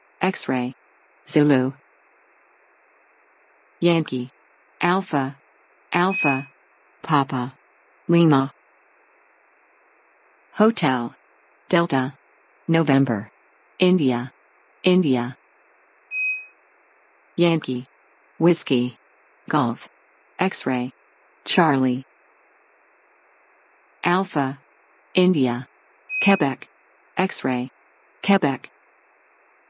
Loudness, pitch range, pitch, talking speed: -22 LUFS, 130-180 Hz, 140 Hz, 45 wpm